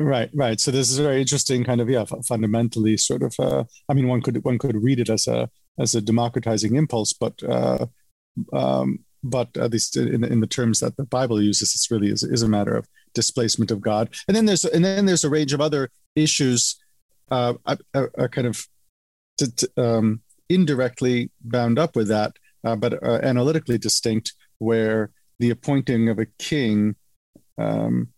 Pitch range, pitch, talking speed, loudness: 110-135 Hz, 120 Hz, 185 wpm, -22 LUFS